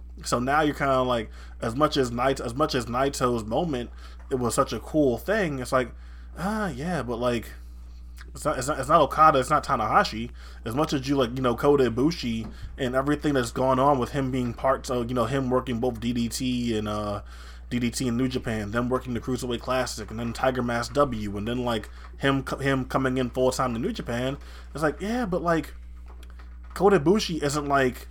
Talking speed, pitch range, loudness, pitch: 215 wpm, 110-135 Hz, -25 LUFS, 125 Hz